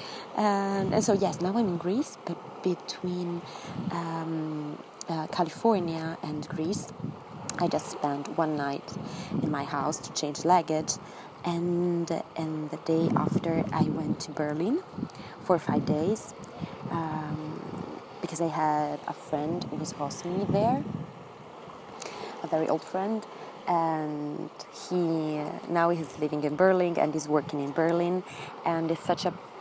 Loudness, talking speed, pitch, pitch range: -29 LUFS, 140 wpm, 165 Hz, 155-180 Hz